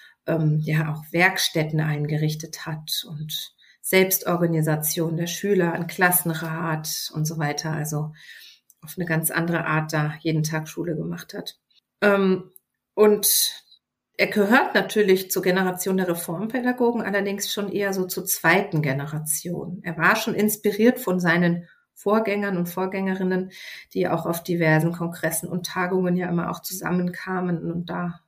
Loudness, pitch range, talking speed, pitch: -23 LUFS, 160-190 Hz, 135 wpm, 175 Hz